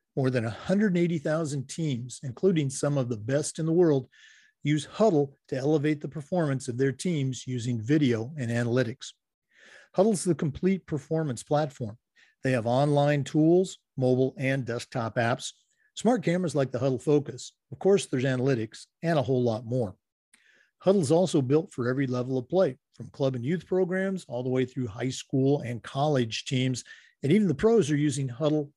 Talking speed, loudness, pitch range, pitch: 175 wpm, -27 LUFS, 125-160 Hz, 140 Hz